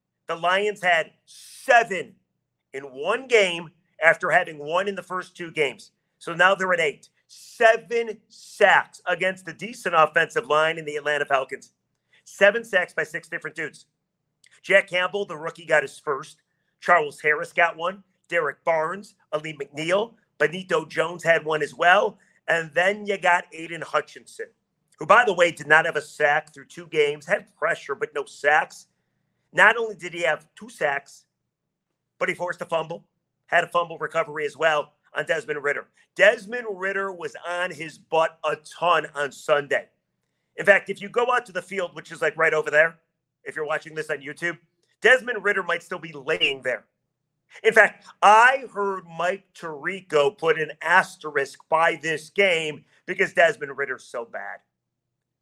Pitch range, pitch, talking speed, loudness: 155-195 Hz, 170 Hz, 170 wpm, -22 LUFS